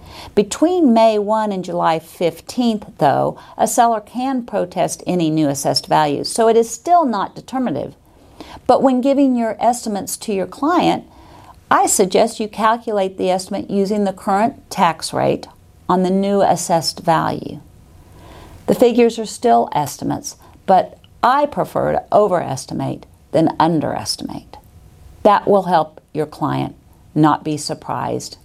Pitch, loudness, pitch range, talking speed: 205 Hz, -17 LUFS, 170-235 Hz, 135 wpm